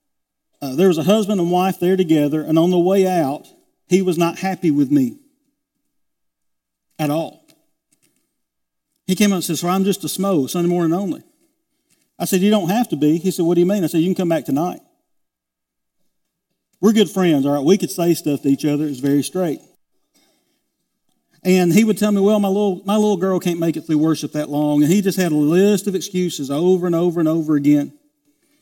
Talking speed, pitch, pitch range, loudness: 215 wpm, 175 Hz, 150-200 Hz, -18 LUFS